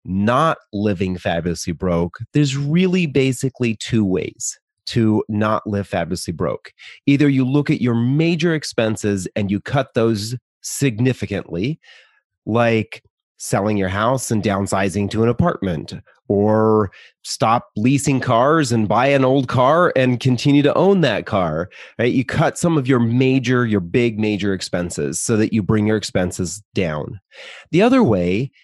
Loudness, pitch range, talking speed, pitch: -18 LUFS, 100-130 Hz, 150 wpm, 115 Hz